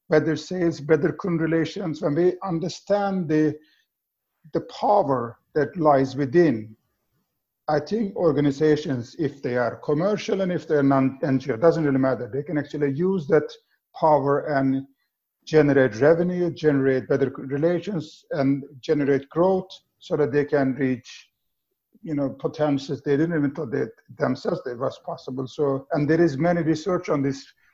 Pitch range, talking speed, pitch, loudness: 140-170 Hz, 150 wpm, 150 Hz, -23 LUFS